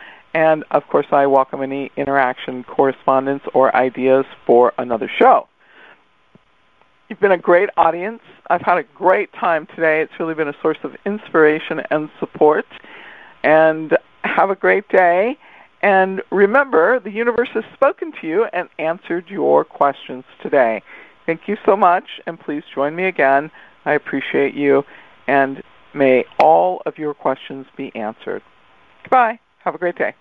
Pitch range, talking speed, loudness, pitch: 135-195 Hz, 150 wpm, -17 LUFS, 160 Hz